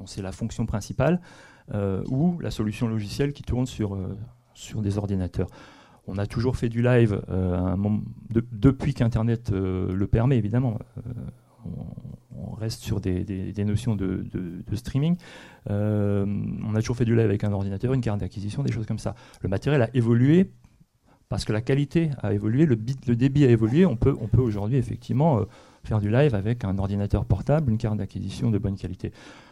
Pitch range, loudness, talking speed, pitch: 100-125 Hz, -25 LUFS, 195 wpm, 110 Hz